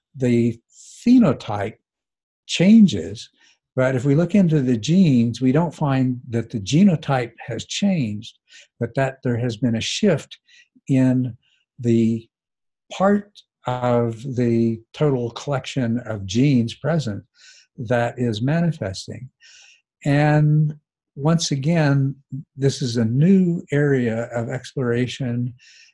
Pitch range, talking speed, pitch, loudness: 120-155 Hz, 110 wpm, 130 Hz, -20 LUFS